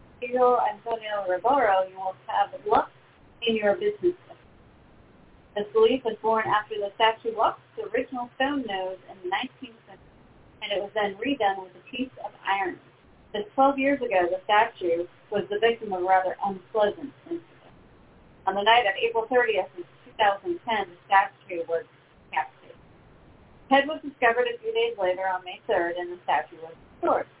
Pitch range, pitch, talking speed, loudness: 190-250 Hz, 215 Hz, 170 wpm, -26 LUFS